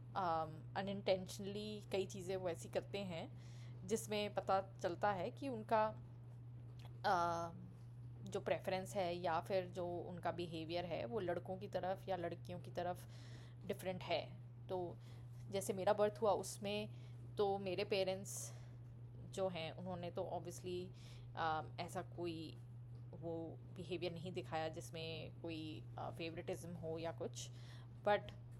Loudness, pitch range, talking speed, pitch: -44 LUFS, 120-180 Hz, 135 wpm, 160 Hz